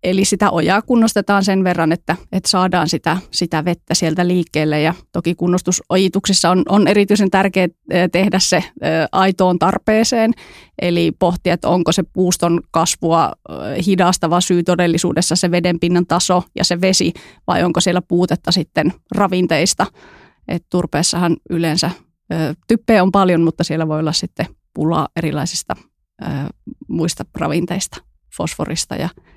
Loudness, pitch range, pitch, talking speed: -16 LUFS, 170-190 Hz, 180 Hz, 135 wpm